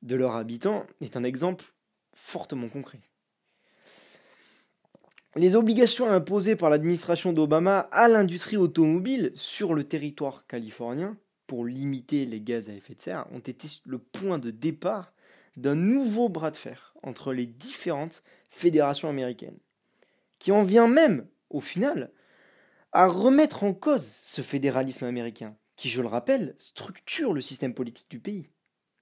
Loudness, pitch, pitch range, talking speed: -26 LUFS, 155 Hz, 130-195 Hz, 140 wpm